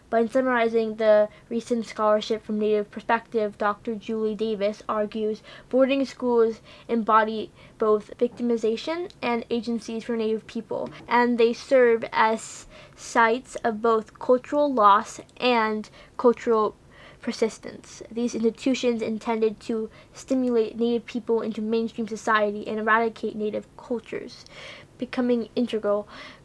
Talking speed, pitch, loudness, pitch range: 115 wpm, 230 Hz, -24 LUFS, 220-240 Hz